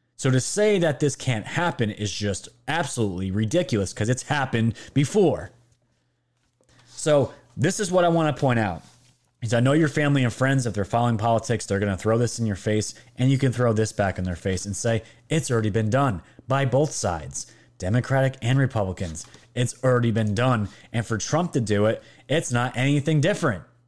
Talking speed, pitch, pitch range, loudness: 195 wpm, 120 Hz, 105-135 Hz, -24 LUFS